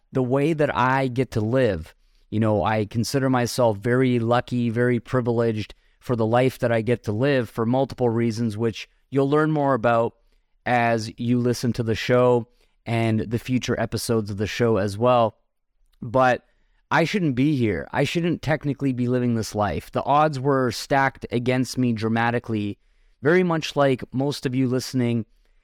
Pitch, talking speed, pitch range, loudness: 120 Hz, 170 wpm, 115-130 Hz, -22 LUFS